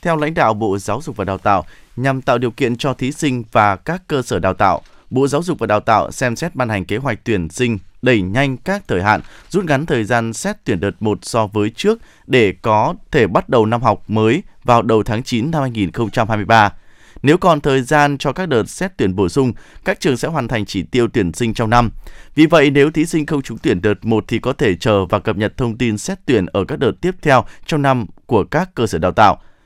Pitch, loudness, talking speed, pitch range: 120 Hz, -16 LUFS, 245 wpm, 110-145 Hz